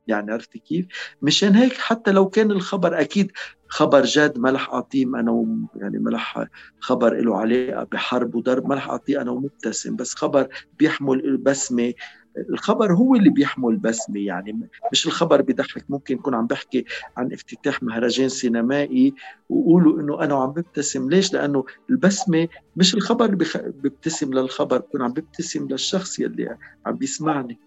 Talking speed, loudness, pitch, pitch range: 150 wpm, -21 LUFS, 145 Hz, 130-190 Hz